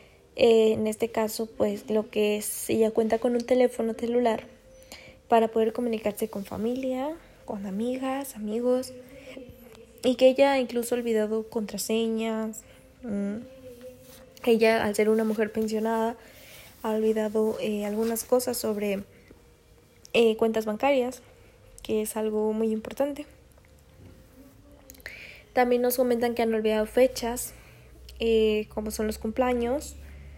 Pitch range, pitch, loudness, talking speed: 220-245 Hz, 225 Hz, -26 LUFS, 120 wpm